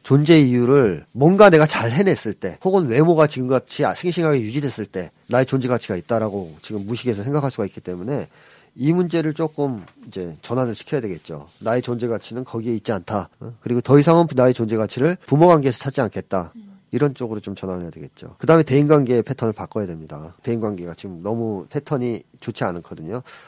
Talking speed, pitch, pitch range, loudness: 420 characters per minute, 125 Hz, 105-145 Hz, -19 LUFS